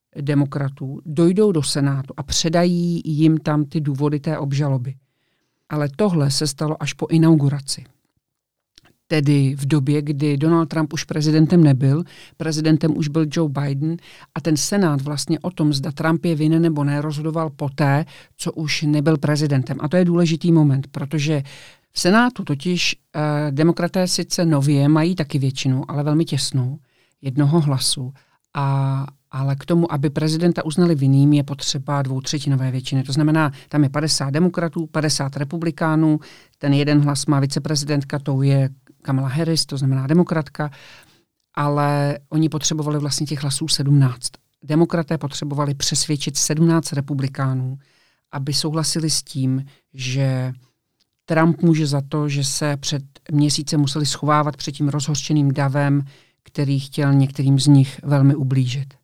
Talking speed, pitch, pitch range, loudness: 145 wpm, 150 Hz, 140-160 Hz, -19 LUFS